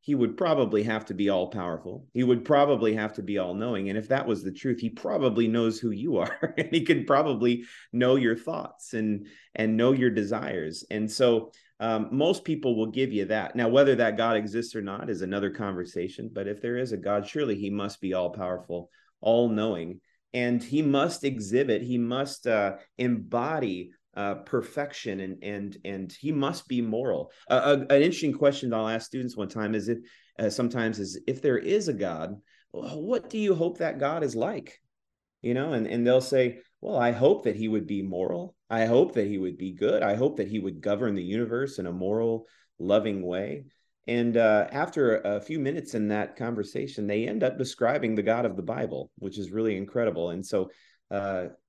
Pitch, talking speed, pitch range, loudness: 115 Hz, 210 wpm, 100-125 Hz, -27 LUFS